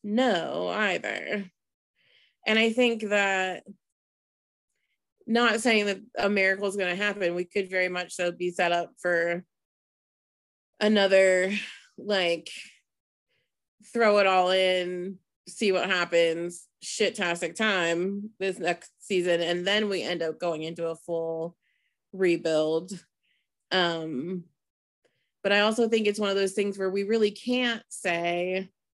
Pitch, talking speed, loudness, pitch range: 185 Hz, 135 wpm, -26 LUFS, 175-205 Hz